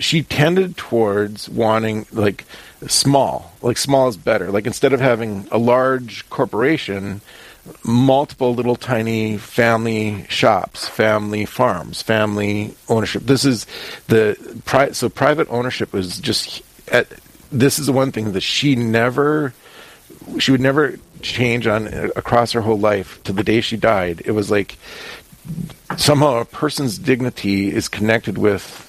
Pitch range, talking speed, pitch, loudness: 105-135 Hz, 140 wpm, 115 Hz, -18 LUFS